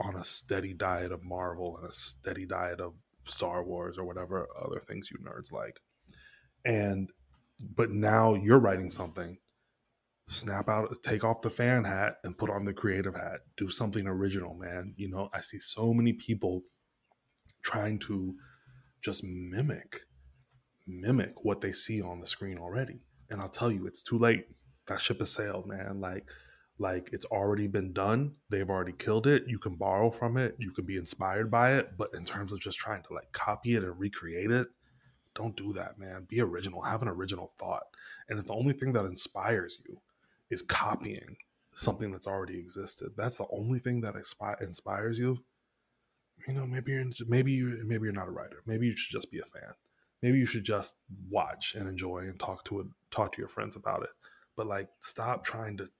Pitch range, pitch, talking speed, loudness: 95-115 Hz, 105 Hz, 195 wpm, -33 LUFS